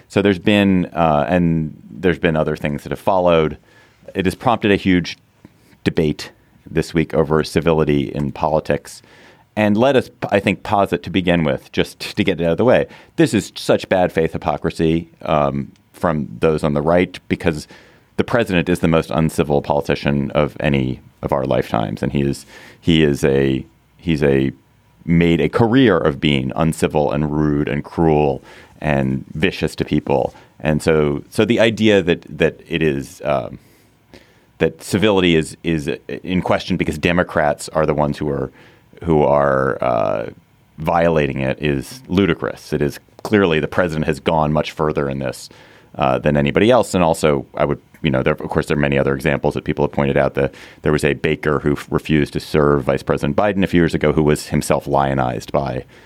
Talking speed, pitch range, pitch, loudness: 185 wpm, 70-85 Hz, 80 Hz, -18 LUFS